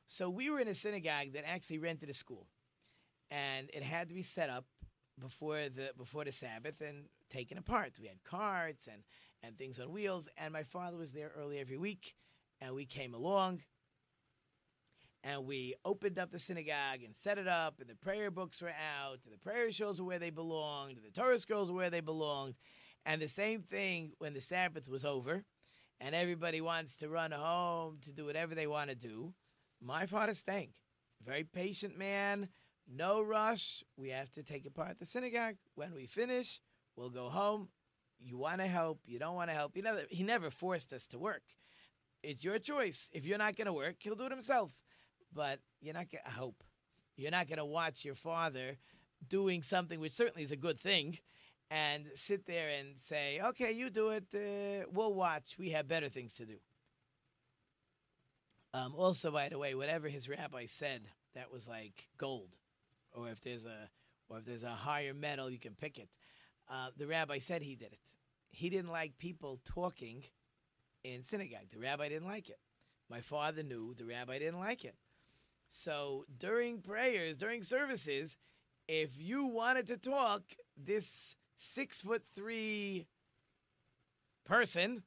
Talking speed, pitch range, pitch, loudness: 185 wpm, 135-185 Hz, 155 Hz, -40 LUFS